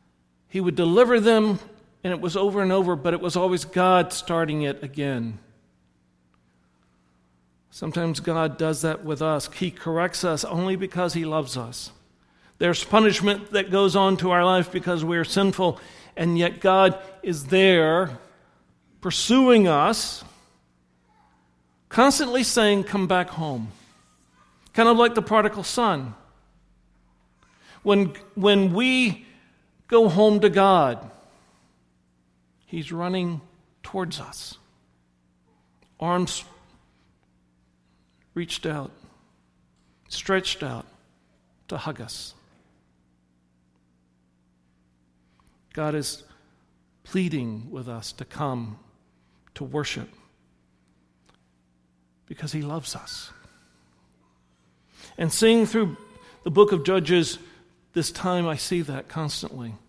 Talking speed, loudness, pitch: 105 wpm, -22 LUFS, 150 Hz